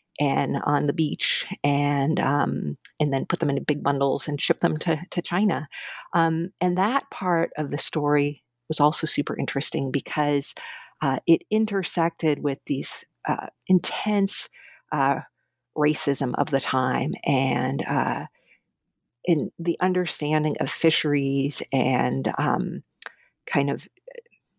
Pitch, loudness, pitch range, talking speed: 150 Hz, -24 LUFS, 140-170 Hz, 130 wpm